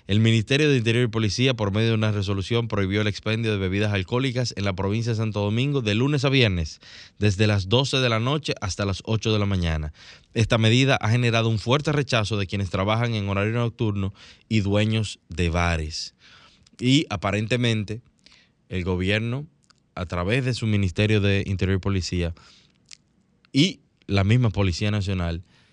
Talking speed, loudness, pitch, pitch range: 175 wpm, -23 LUFS, 105 Hz, 100-120 Hz